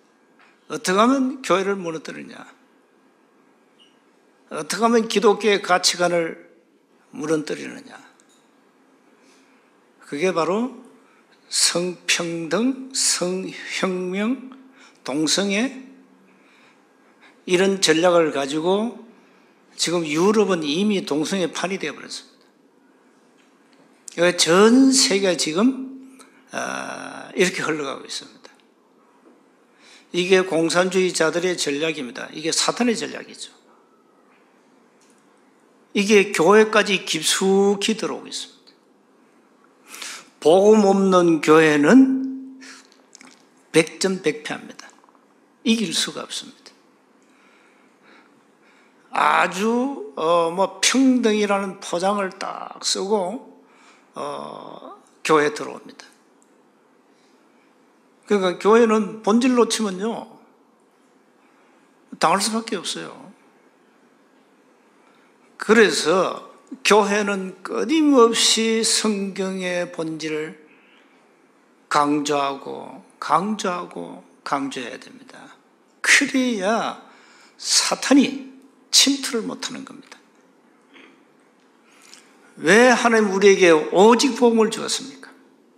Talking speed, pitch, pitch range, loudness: 180 characters per minute, 205 Hz, 175-250 Hz, -19 LUFS